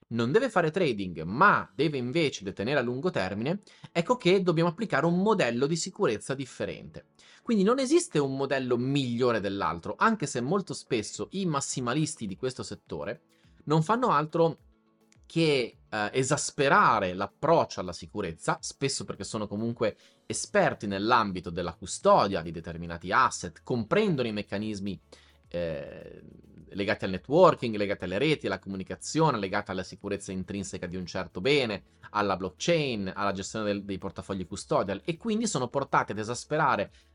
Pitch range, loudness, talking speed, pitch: 100-160 Hz, -28 LUFS, 145 wpm, 120 Hz